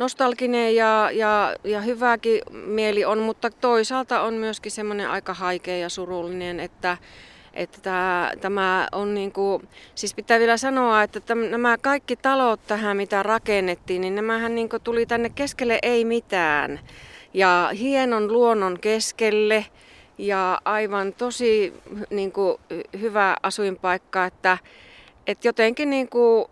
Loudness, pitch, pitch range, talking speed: -22 LUFS, 215 Hz, 190-230 Hz, 130 wpm